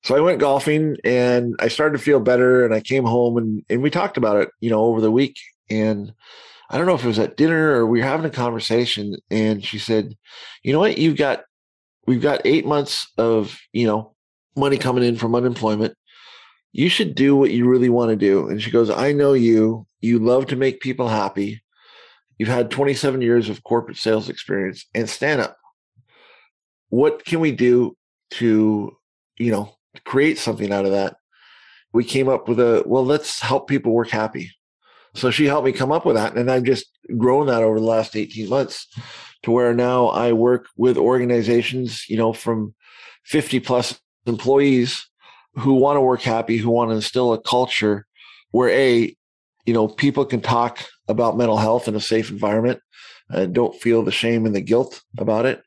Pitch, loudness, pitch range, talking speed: 120 Hz, -19 LUFS, 110-130 Hz, 195 wpm